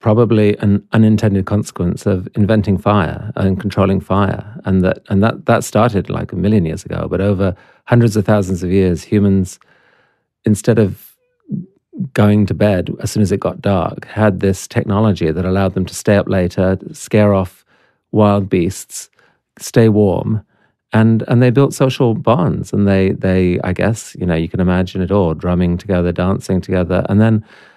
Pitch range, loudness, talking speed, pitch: 95-110 Hz, -15 LUFS, 175 wpm, 100 Hz